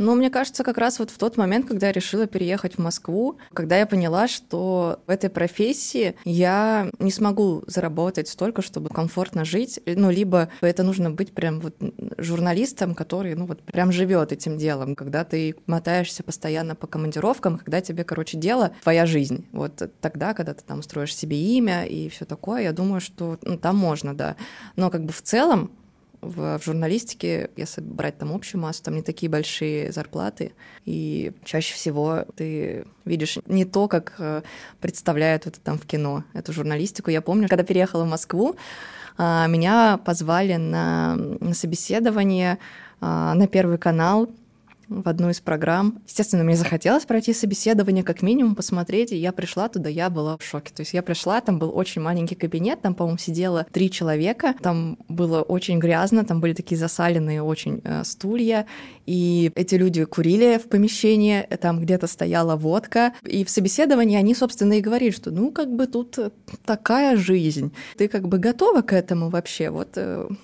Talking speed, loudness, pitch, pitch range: 170 wpm, -23 LUFS, 180 Hz, 165-210 Hz